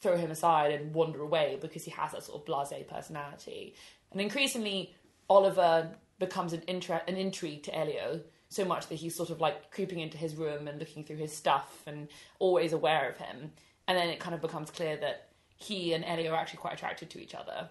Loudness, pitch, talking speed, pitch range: -33 LUFS, 165 Hz, 215 wpm, 155-185 Hz